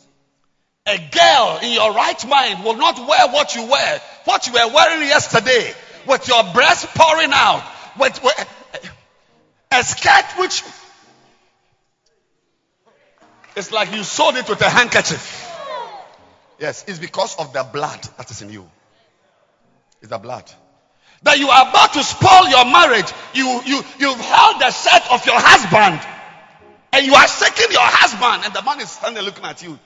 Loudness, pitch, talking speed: -13 LUFS, 250 Hz, 160 wpm